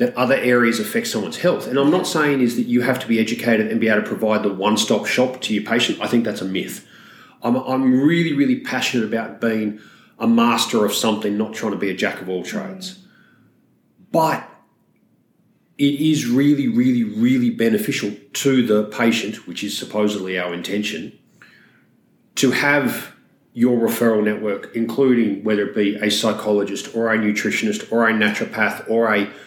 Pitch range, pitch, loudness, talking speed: 105-140 Hz, 115 Hz, -19 LUFS, 170 wpm